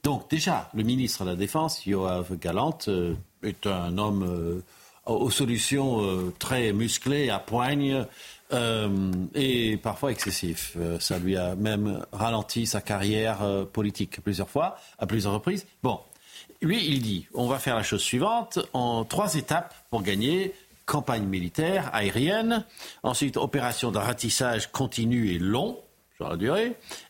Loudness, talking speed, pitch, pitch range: -27 LUFS, 150 wpm, 115 Hz, 100-135 Hz